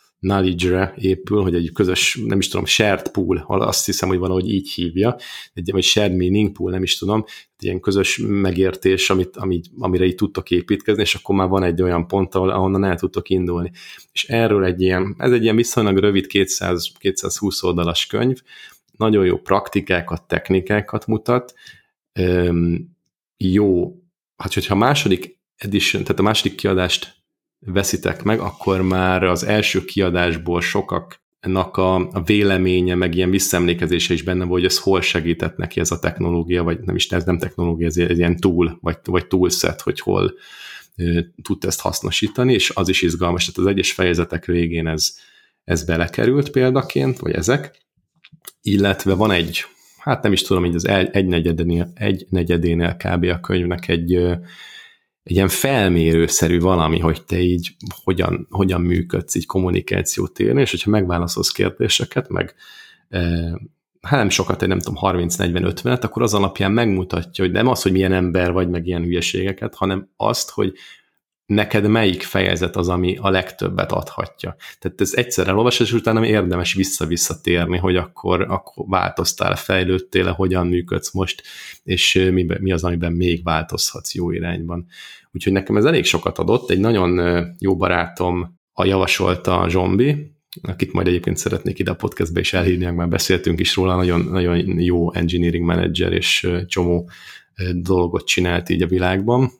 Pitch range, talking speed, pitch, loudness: 85-95 Hz, 160 wpm, 90 Hz, -19 LUFS